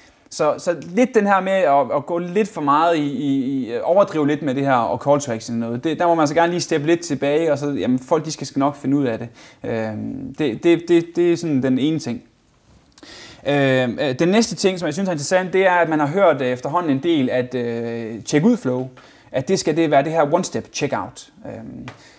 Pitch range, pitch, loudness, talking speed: 130-175 Hz, 150 Hz, -19 LUFS, 240 wpm